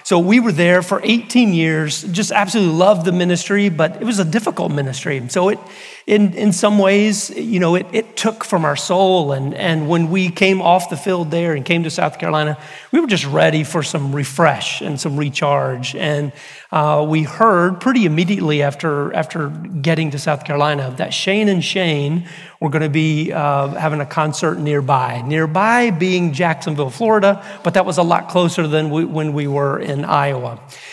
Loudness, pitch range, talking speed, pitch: -16 LUFS, 150-190 Hz, 190 wpm, 165 Hz